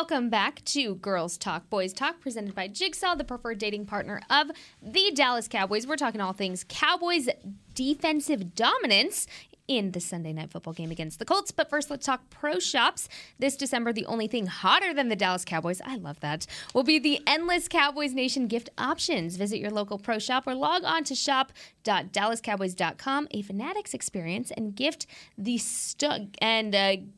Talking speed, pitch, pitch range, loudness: 175 wpm, 235 Hz, 195-290 Hz, -27 LUFS